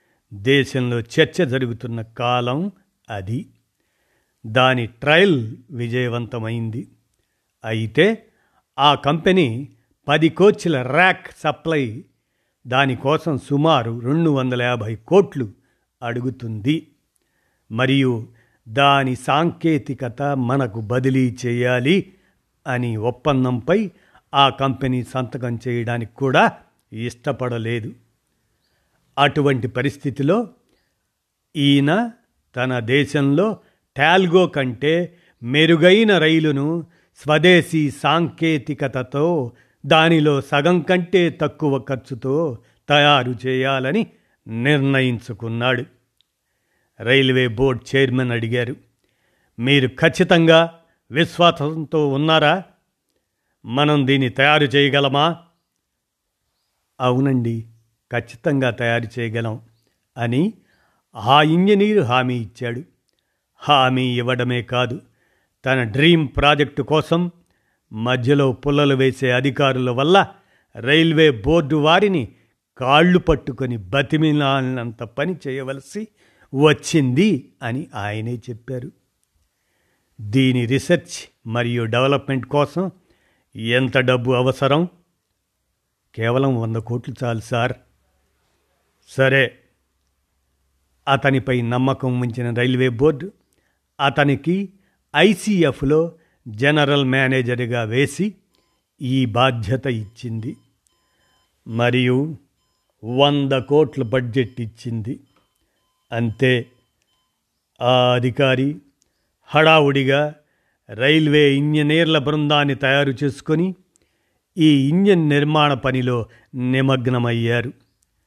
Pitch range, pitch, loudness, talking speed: 120-150 Hz, 135 Hz, -18 LUFS, 75 wpm